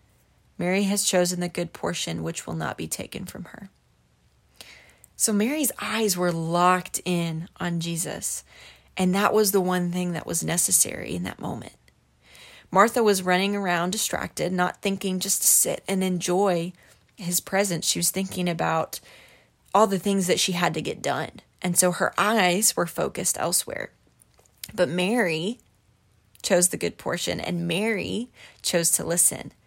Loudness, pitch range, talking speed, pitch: -24 LUFS, 170-200 Hz, 160 wpm, 180 Hz